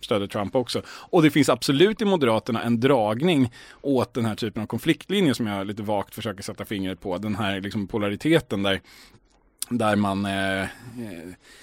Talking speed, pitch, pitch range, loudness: 170 wpm, 110 Hz, 100-130 Hz, -24 LUFS